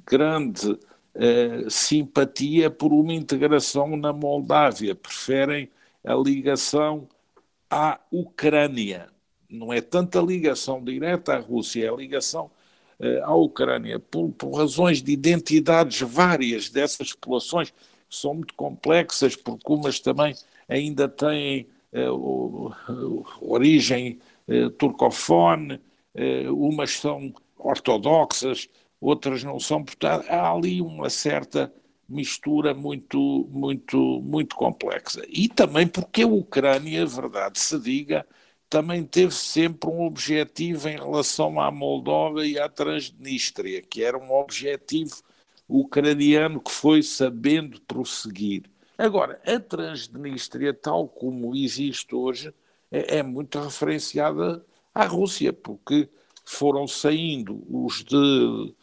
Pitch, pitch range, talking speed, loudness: 145 Hz, 130-160 Hz, 110 wpm, -23 LUFS